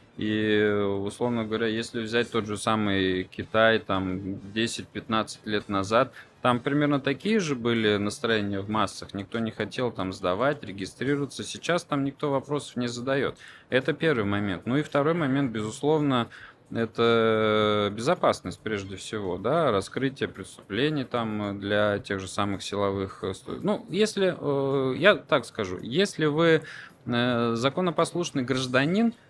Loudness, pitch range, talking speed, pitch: -26 LUFS, 105-140 Hz, 130 wpm, 115 Hz